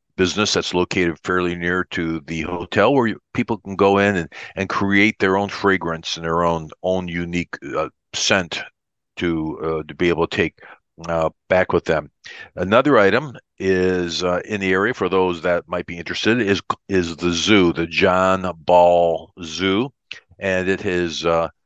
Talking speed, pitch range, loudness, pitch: 175 wpm, 85-95 Hz, -19 LUFS, 90 Hz